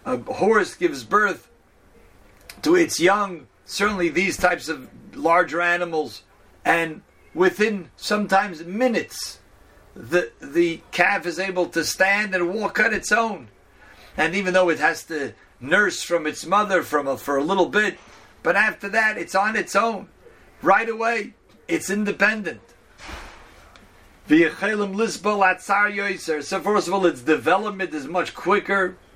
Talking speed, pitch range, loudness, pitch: 135 wpm, 170-210 Hz, -21 LUFS, 190 Hz